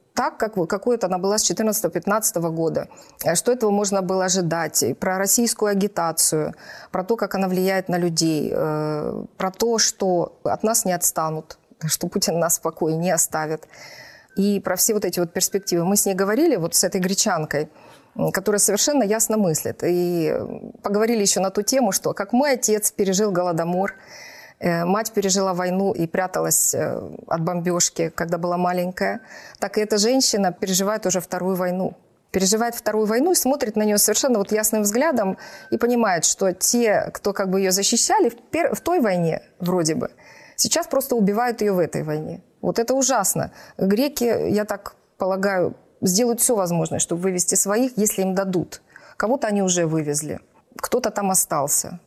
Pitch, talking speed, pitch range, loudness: 195 Hz, 170 wpm, 180-220 Hz, -21 LUFS